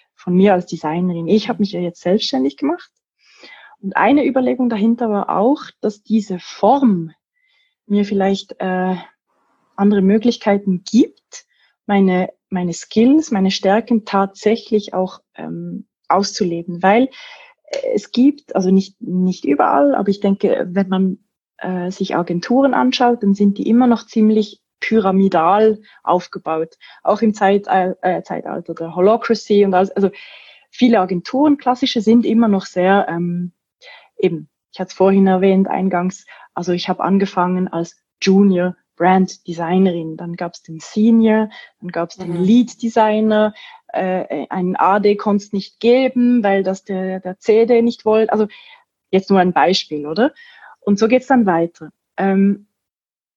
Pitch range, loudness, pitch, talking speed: 185-230 Hz, -16 LUFS, 200 Hz, 140 wpm